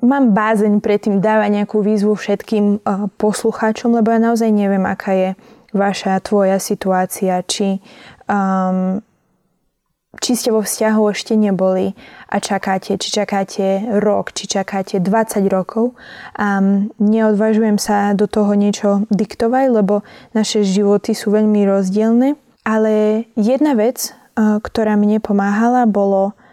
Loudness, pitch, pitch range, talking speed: -16 LUFS, 210 Hz, 200-220 Hz, 130 wpm